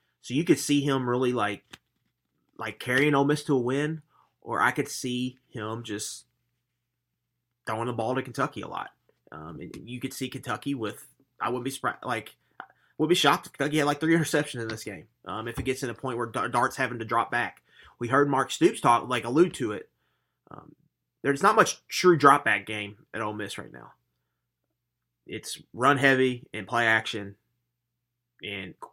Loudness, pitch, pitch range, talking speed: -26 LUFS, 125 Hz, 115-140 Hz, 195 wpm